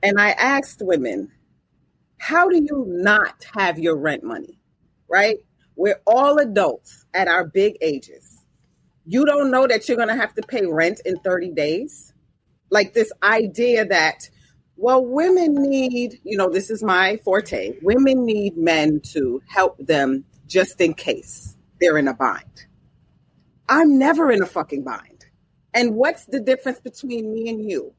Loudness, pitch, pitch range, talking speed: -19 LUFS, 220 Hz, 185-265 Hz, 155 wpm